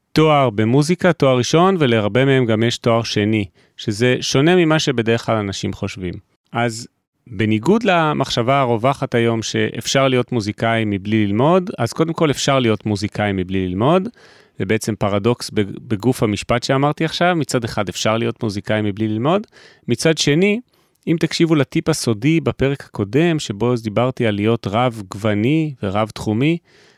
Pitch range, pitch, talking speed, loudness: 110-150 Hz, 120 Hz, 145 wpm, -18 LUFS